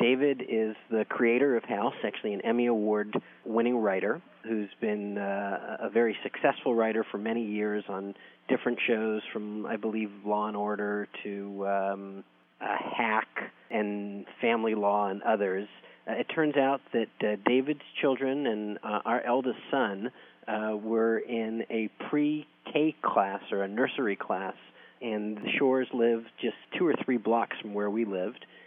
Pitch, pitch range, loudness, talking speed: 110 Hz, 105-115 Hz, -30 LUFS, 155 wpm